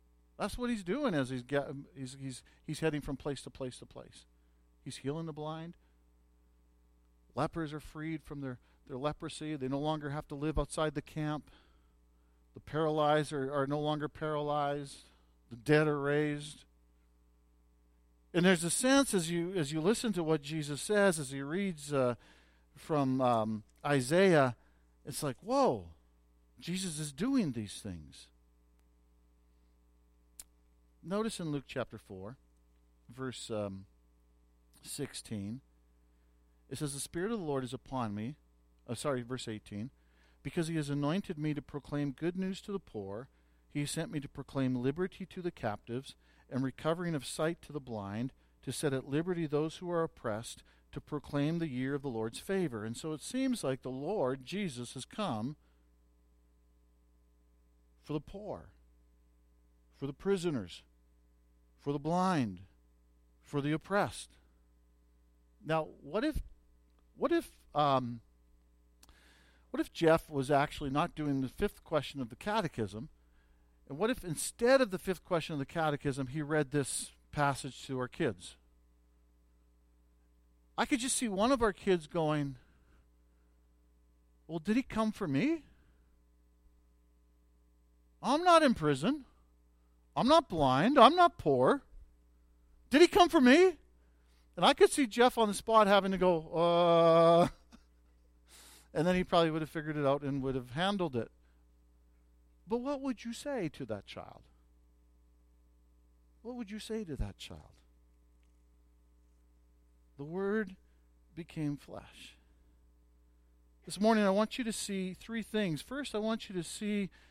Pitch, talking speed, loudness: 130 Hz, 150 wpm, -33 LUFS